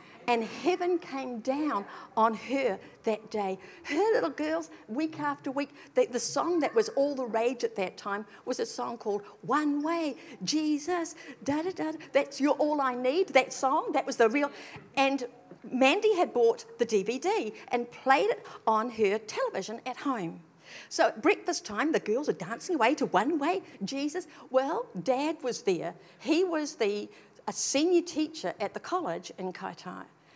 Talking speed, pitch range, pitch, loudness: 170 wpm, 230-320 Hz, 275 Hz, -30 LUFS